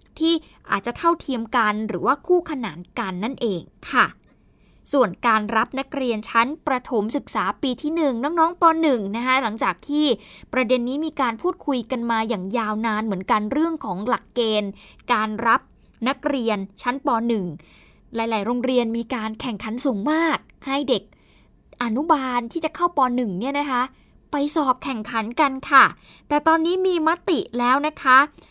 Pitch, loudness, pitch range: 255 Hz, -22 LUFS, 225-290 Hz